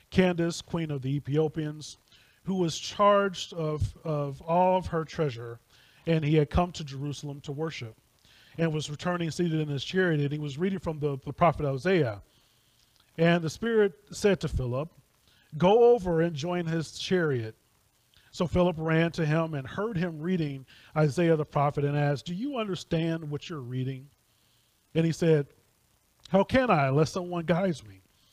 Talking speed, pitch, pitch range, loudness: 170 wpm, 155 Hz, 140-175 Hz, -28 LUFS